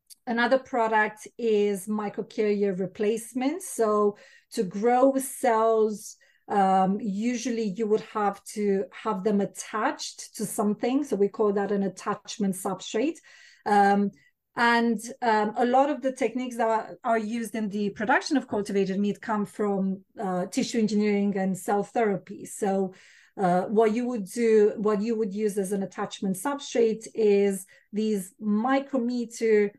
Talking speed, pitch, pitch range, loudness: 140 wpm, 215 Hz, 200-235 Hz, -26 LUFS